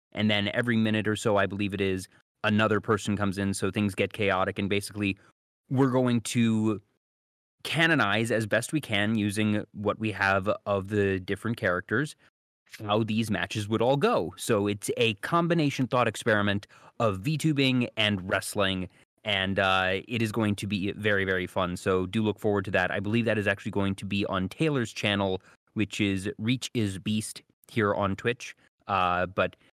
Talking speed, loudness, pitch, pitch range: 180 wpm, -27 LUFS, 105 Hz, 100-110 Hz